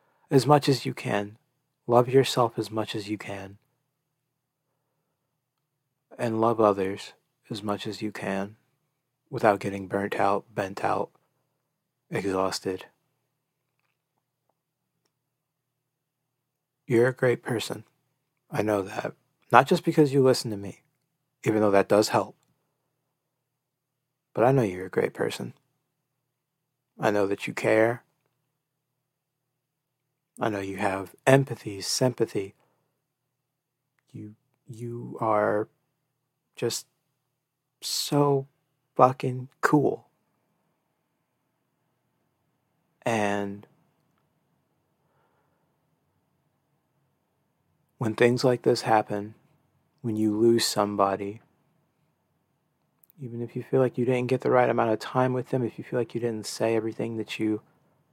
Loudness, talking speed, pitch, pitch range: -26 LUFS, 110 wpm, 130 Hz, 110-145 Hz